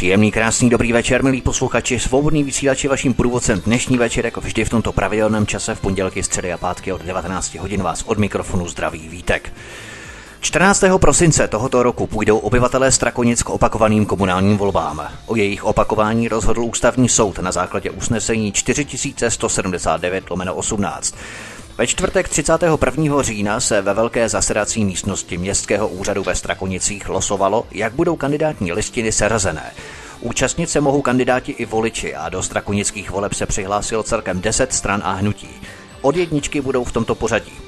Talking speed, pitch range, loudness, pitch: 150 wpm, 100-130 Hz, -18 LUFS, 110 Hz